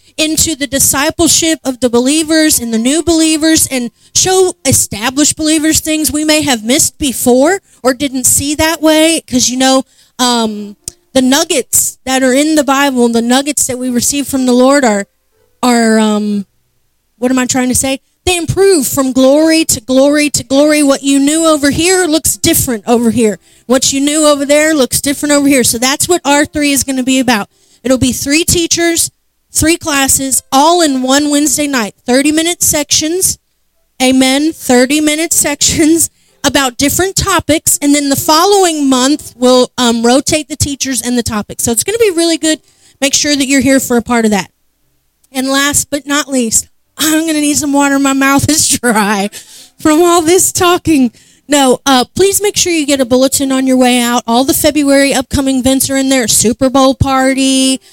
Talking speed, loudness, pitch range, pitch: 190 wpm, -10 LUFS, 255-310 Hz, 275 Hz